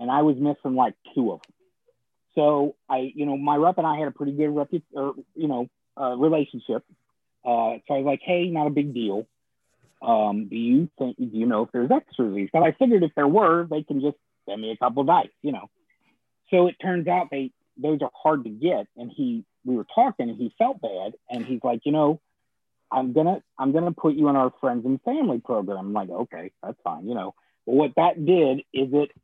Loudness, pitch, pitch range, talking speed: -24 LUFS, 145 Hz, 125-155 Hz, 235 wpm